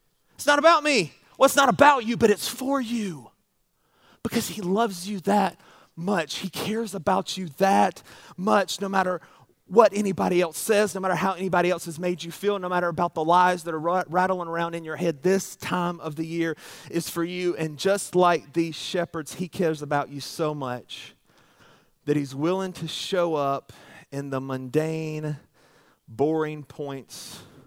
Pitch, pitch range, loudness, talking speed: 175 Hz, 160-195 Hz, -25 LUFS, 180 wpm